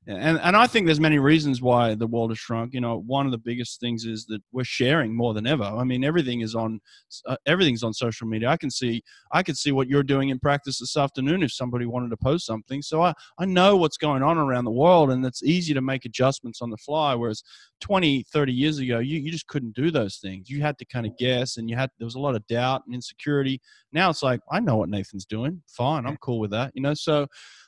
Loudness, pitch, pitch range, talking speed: -24 LUFS, 130 Hz, 120-150 Hz, 260 wpm